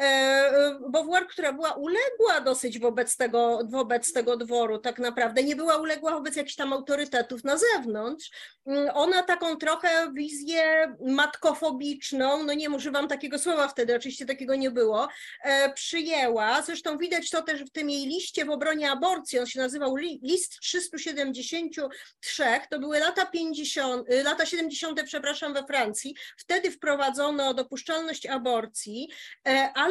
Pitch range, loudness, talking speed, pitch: 265-320 Hz, -27 LUFS, 135 wpm, 290 Hz